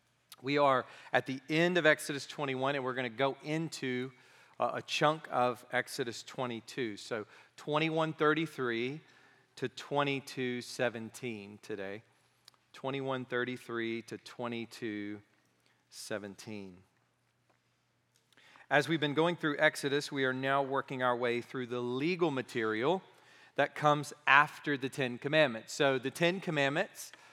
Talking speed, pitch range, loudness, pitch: 115 wpm, 120-150 Hz, -33 LUFS, 130 Hz